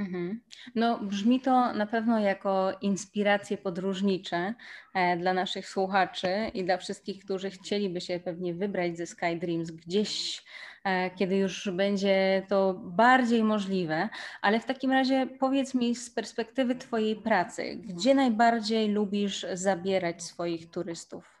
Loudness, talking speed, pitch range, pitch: -28 LUFS, 125 wpm, 185-225 Hz, 200 Hz